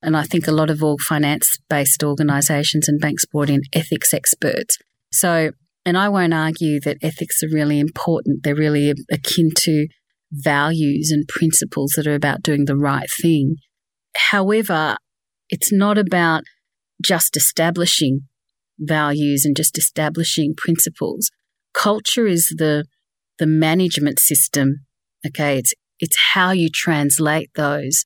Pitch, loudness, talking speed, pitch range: 155 Hz, -17 LUFS, 135 wpm, 145-165 Hz